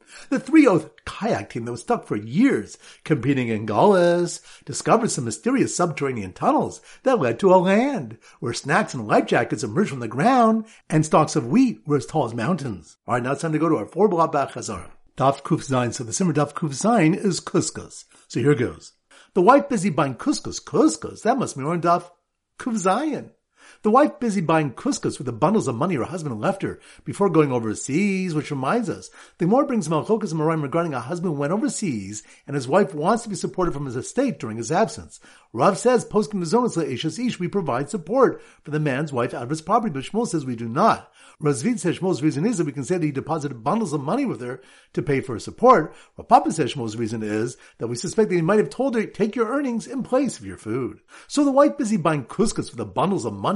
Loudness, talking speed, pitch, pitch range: -22 LUFS, 220 wpm, 165 Hz, 140-210 Hz